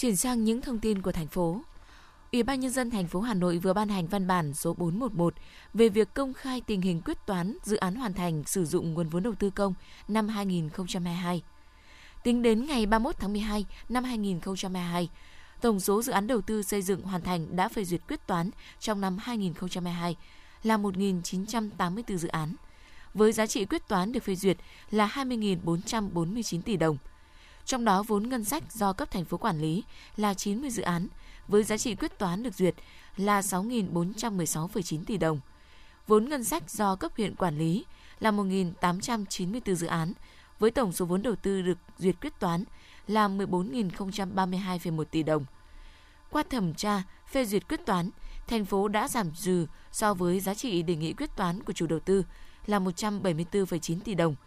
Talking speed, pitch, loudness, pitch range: 185 wpm, 195 Hz, -30 LUFS, 175-220 Hz